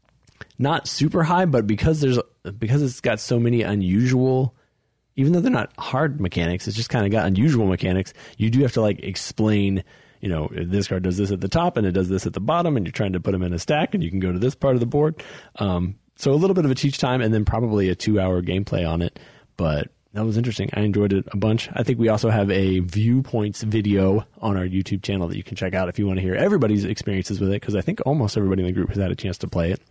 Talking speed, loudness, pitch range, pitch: 270 wpm, -22 LUFS, 95-120 Hz, 105 Hz